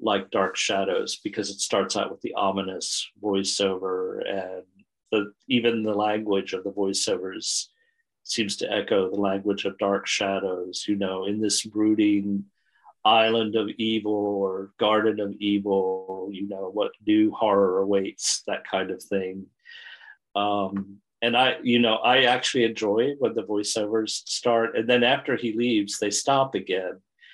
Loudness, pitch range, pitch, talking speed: -25 LUFS, 100-115 Hz, 105 Hz, 155 wpm